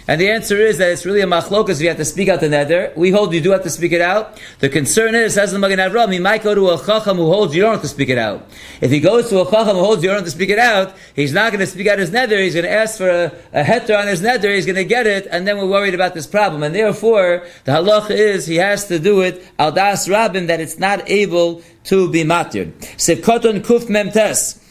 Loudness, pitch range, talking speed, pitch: -15 LUFS, 175-210 Hz, 280 wpm, 195 Hz